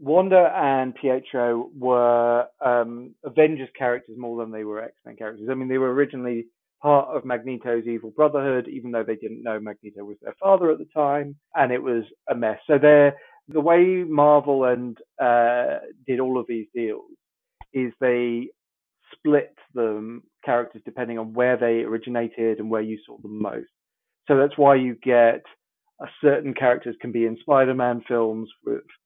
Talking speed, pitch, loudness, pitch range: 170 wpm, 125 Hz, -22 LUFS, 115-140 Hz